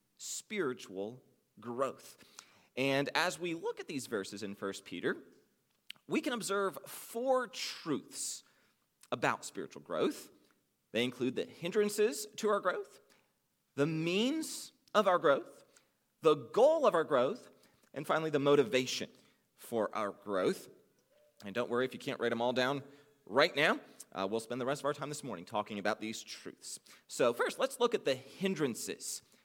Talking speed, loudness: 155 wpm, -34 LUFS